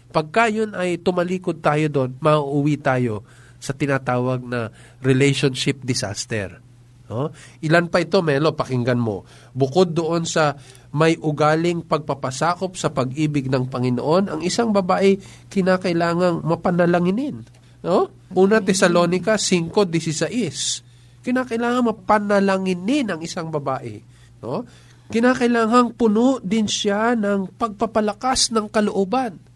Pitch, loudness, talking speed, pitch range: 165 Hz, -20 LUFS, 110 wpm, 130-200 Hz